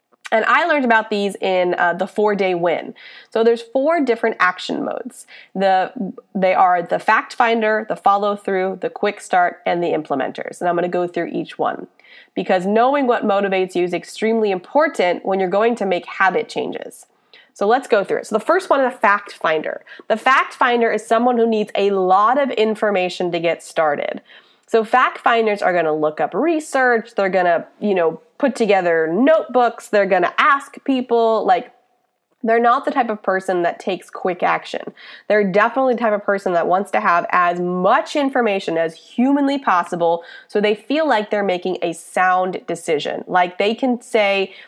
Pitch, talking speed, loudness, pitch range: 210 Hz, 190 wpm, -18 LUFS, 185-240 Hz